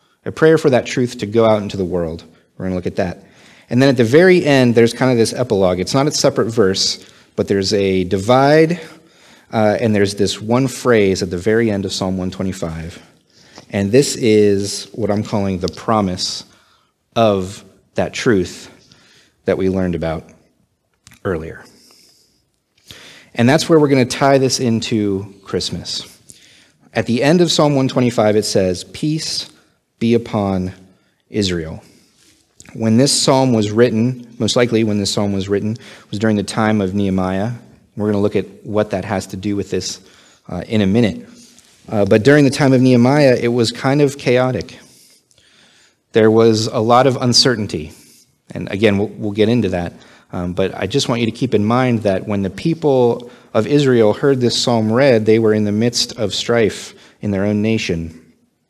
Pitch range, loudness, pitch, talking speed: 100-125 Hz, -16 LUFS, 110 Hz, 180 wpm